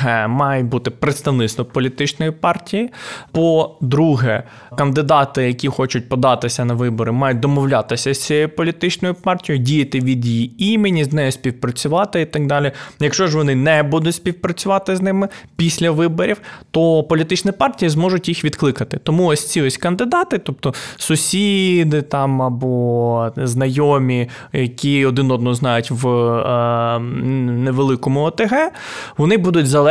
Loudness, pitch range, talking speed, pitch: -17 LUFS, 130-170 Hz, 130 wpm, 145 Hz